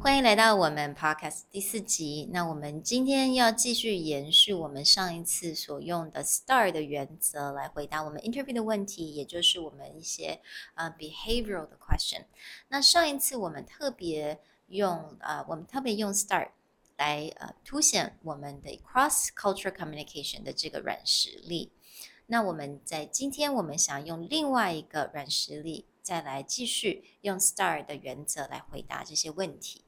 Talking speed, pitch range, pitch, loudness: 360 characters per minute, 150-225 Hz, 170 Hz, -28 LUFS